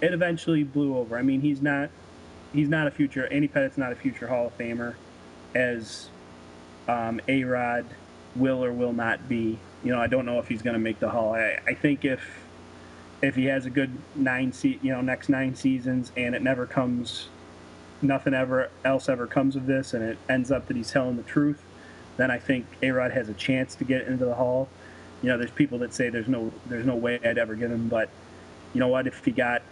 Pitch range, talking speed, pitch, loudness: 110-135 Hz, 220 wpm, 125 Hz, -27 LUFS